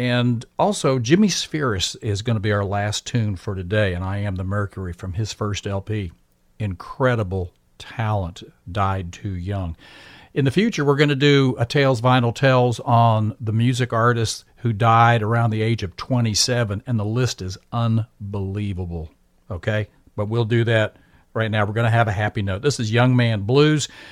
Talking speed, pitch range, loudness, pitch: 180 wpm, 100-120 Hz, -21 LUFS, 110 Hz